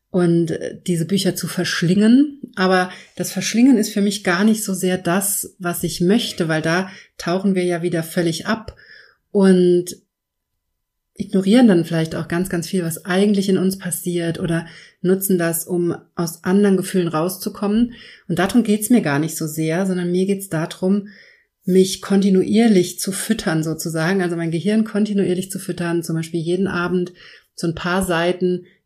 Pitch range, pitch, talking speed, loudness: 170-195 Hz, 180 Hz, 170 wpm, -19 LUFS